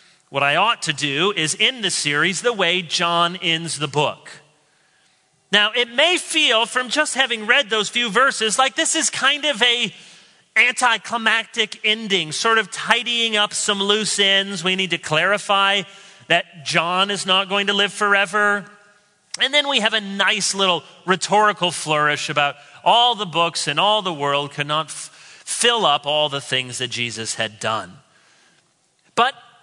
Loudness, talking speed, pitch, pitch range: -18 LUFS, 165 wpm, 195 Hz, 160-220 Hz